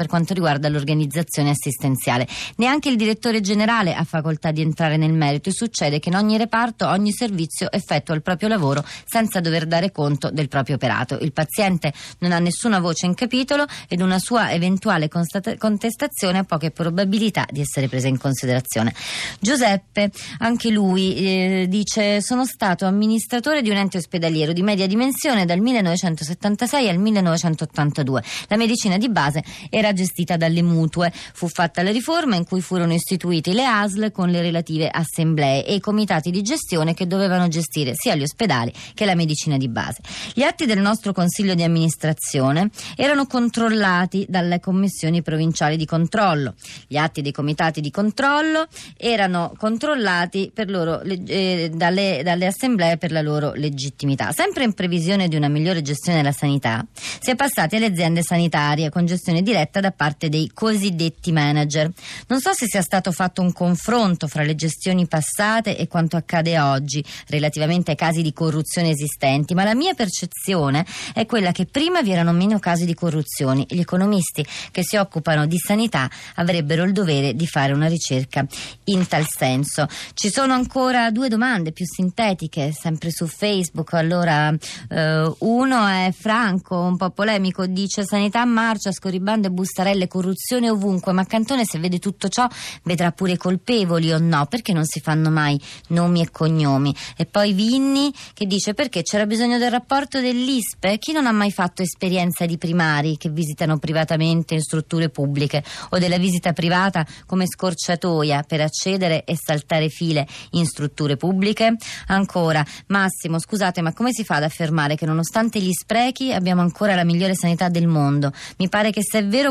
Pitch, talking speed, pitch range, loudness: 175 Hz, 165 wpm, 155-205 Hz, -20 LUFS